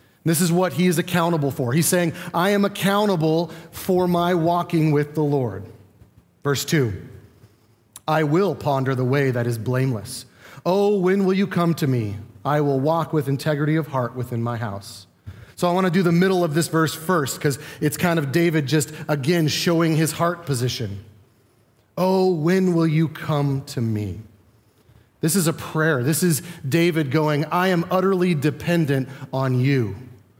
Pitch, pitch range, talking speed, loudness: 155 Hz, 125-170 Hz, 175 wpm, -21 LUFS